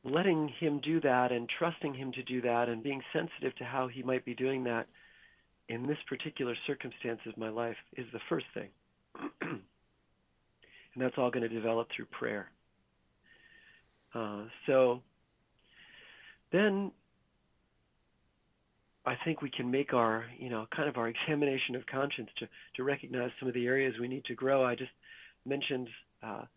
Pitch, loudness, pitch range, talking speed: 130 Hz, -34 LUFS, 120-140 Hz, 160 wpm